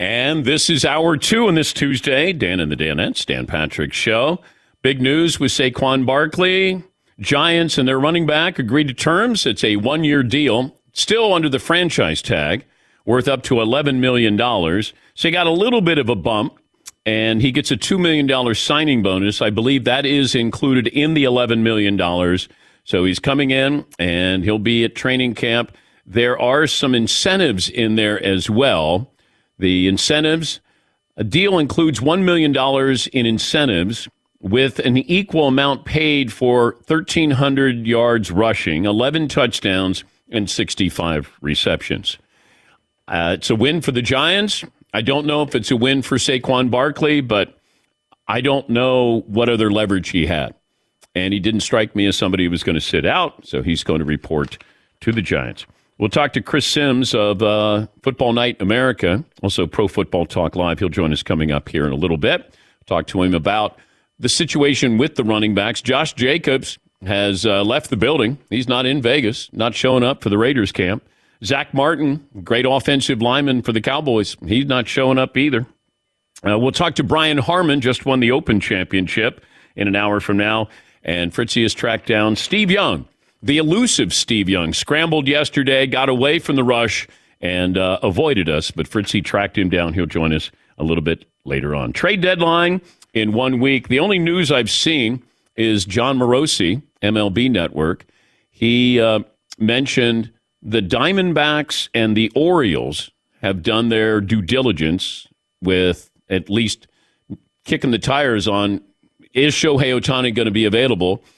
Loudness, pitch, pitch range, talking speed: -17 LUFS, 120 Hz, 105-140 Hz, 170 wpm